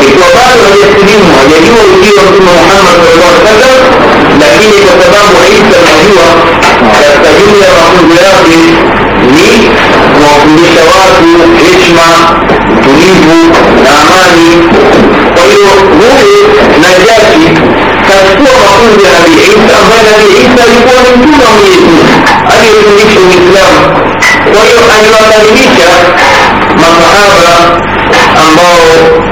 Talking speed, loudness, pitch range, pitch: 105 wpm, -1 LUFS, 170-220 Hz, 190 Hz